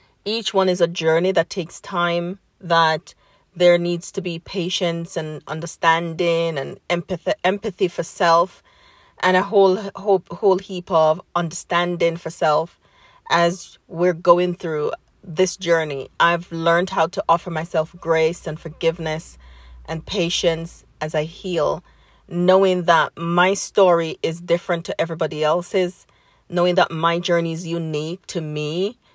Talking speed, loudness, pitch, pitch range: 140 wpm, -20 LUFS, 170 Hz, 165-185 Hz